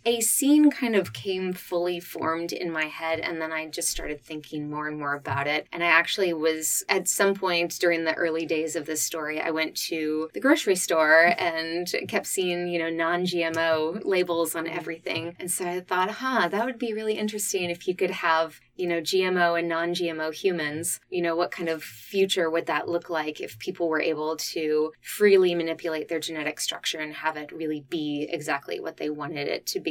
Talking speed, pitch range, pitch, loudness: 210 wpm, 160-180 Hz, 165 Hz, -26 LUFS